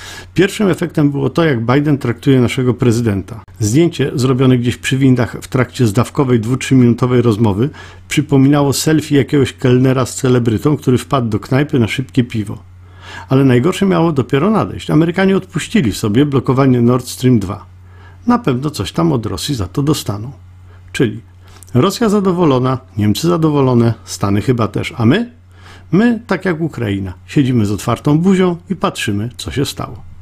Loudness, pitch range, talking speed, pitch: -14 LUFS, 105-145 Hz, 150 wpm, 125 Hz